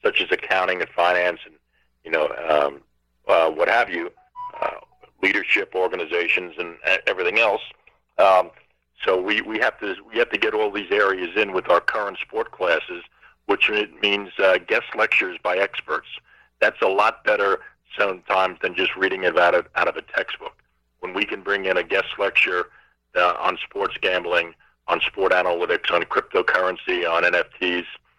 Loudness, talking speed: -21 LUFS, 170 wpm